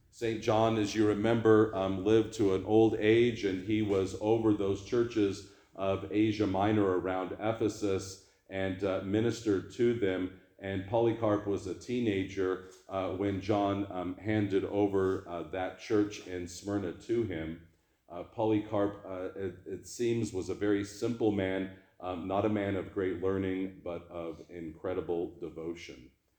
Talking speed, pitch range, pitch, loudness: 150 wpm, 95-110 Hz, 100 Hz, -32 LUFS